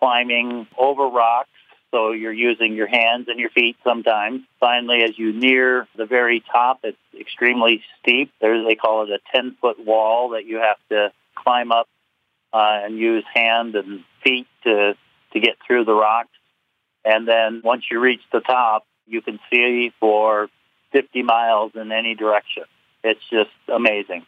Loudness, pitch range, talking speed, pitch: -18 LUFS, 110-120 Hz, 165 wpm, 115 Hz